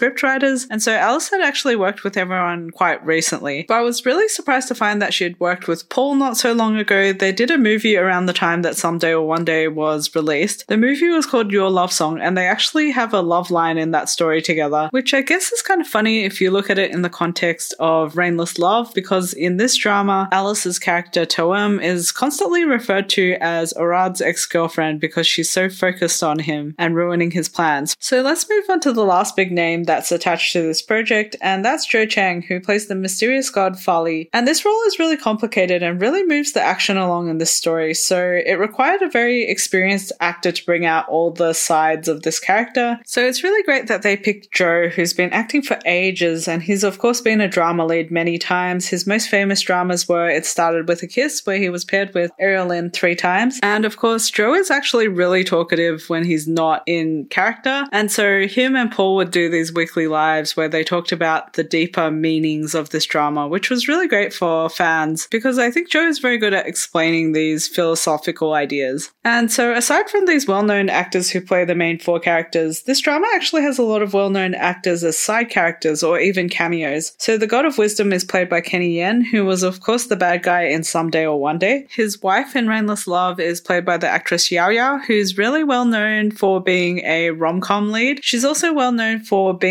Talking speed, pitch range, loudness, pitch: 220 wpm, 170-225 Hz, -17 LUFS, 185 Hz